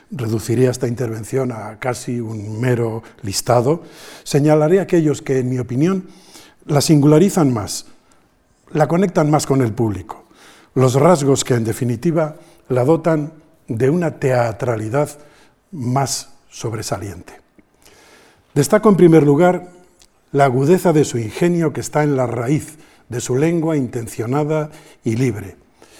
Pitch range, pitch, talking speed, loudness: 120-155 Hz, 140 Hz, 125 wpm, -17 LUFS